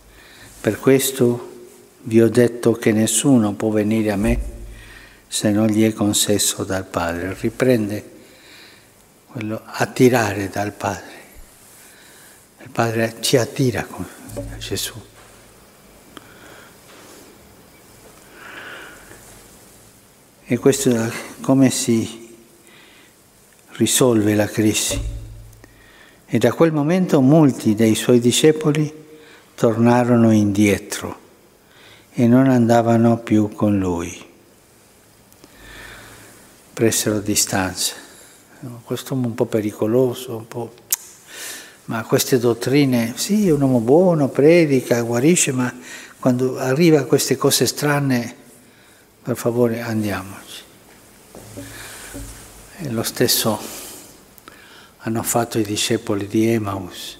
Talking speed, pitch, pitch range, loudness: 95 wpm, 115 Hz, 110-130 Hz, -18 LUFS